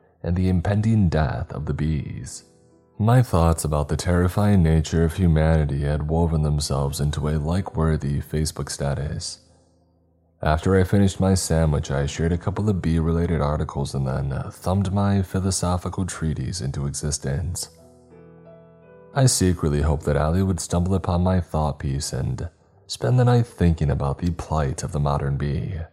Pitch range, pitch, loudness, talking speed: 75-90 Hz, 80 Hz, -23 LUFS, 155 wpm